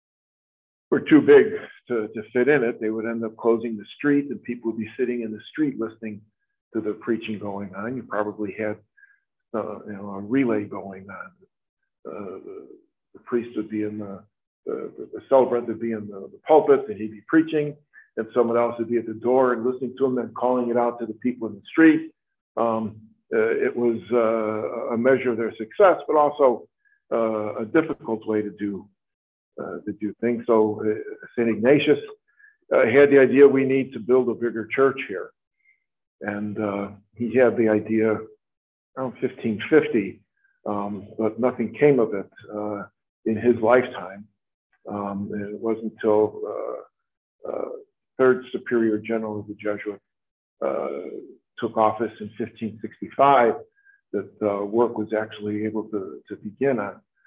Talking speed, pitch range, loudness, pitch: 175 wpm, 105-140 Hz, -23 LUFS, 115 Hz